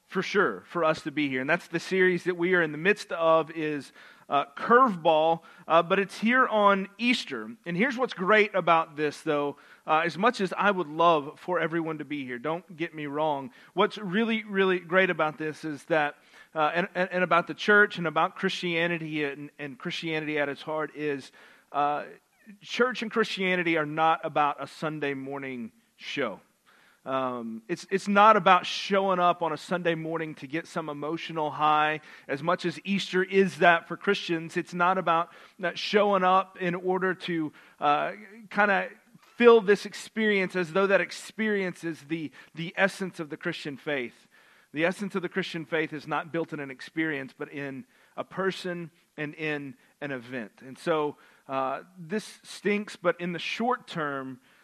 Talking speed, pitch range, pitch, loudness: 180 wpm, 150-190 Hz, 170 Hz, -27 LUFS